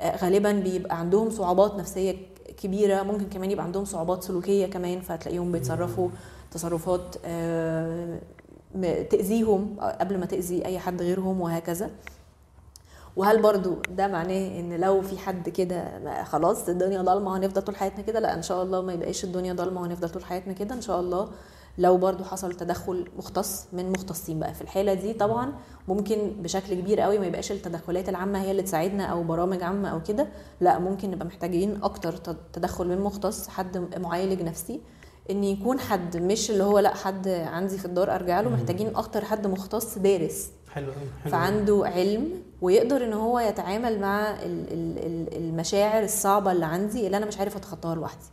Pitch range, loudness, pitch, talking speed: 175-200 Hz, -27 LUFS, 190 Hz, 165 wpm